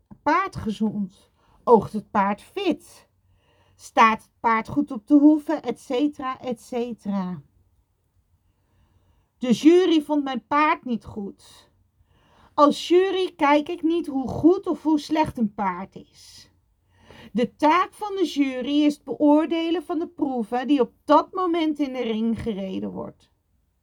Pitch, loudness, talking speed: 240 Hz, -22 LUFS, 140 wpm